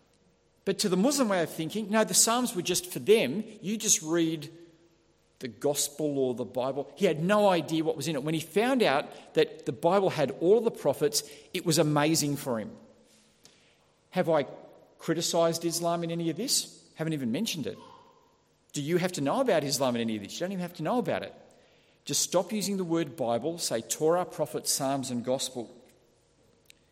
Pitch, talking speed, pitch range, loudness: 165 Hz, 200 wpm, 145-195 Hz, -28 LUFS